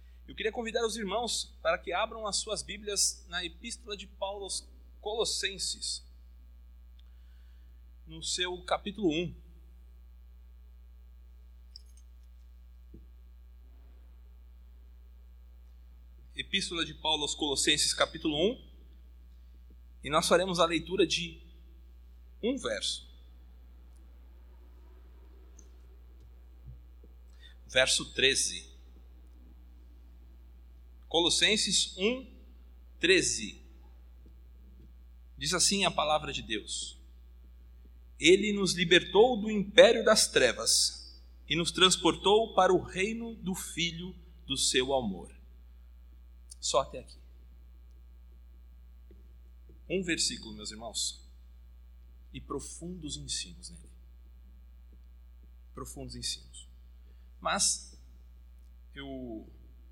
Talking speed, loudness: 80 wpm, -29 LUFS